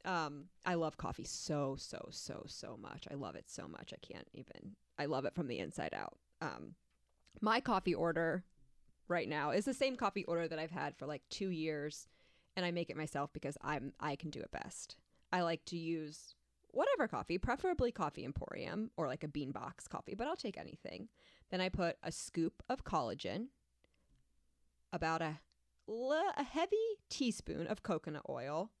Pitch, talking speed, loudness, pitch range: 165 Hz, 185 wpm, -41 LUFS, 145-185 Hz